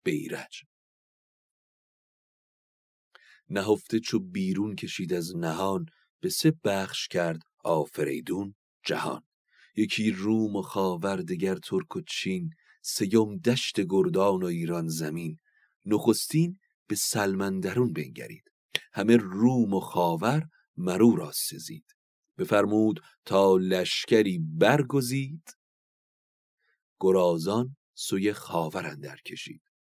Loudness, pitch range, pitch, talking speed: -27 LUFS, 95-135 Hz, 105 Hz, 95 wpm